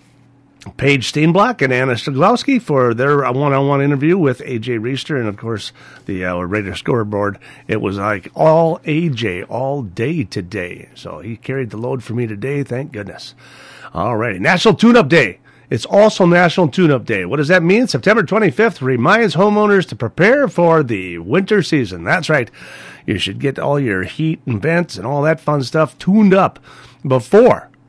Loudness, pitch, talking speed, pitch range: -15 LUFS, 140 Hz, 175 wpm, 115-170 Hz